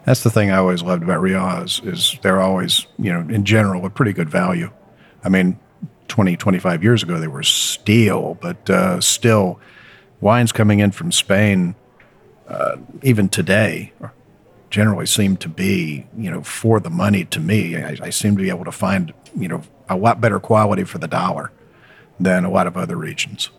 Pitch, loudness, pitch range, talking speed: 100 Hz, -17 LUFS, 95-110 Hz, 185 wpm